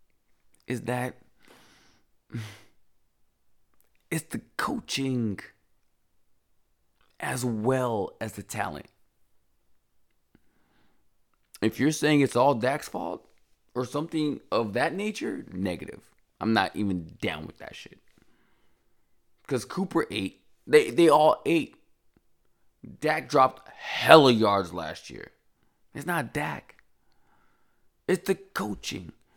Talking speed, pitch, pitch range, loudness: 100 wpm, 125 Hz, 110-160 Hz, -26 LUFS